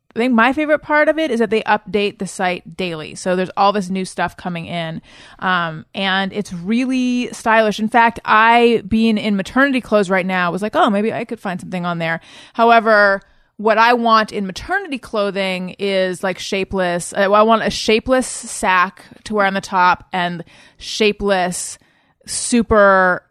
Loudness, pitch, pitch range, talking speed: -16 LUFS, 205 Hz, 185-225 Hz, 180 wpm